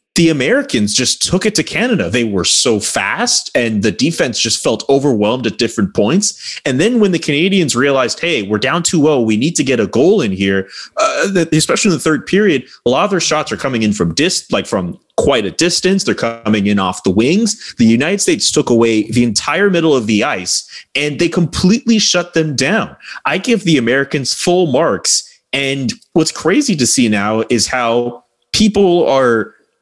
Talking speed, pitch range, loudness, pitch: 200 wpm, 115-185 Hz, -13 LUFS, 150 Hz